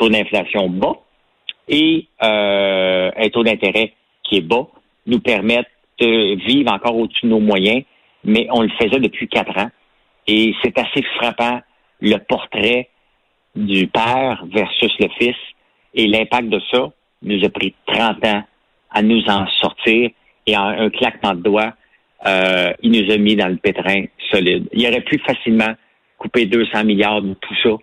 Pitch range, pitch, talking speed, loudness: 105-115 Hz, 110 Hz, 165 wpm, -16 LUFS